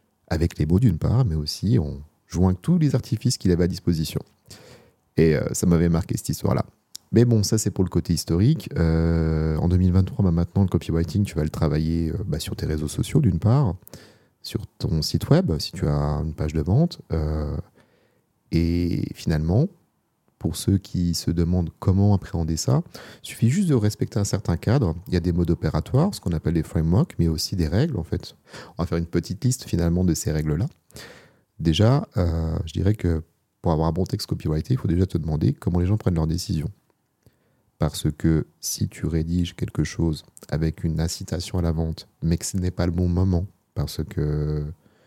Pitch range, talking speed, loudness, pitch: 80-105 Hz, 200 wpm, -23 LUFS, 85 Hz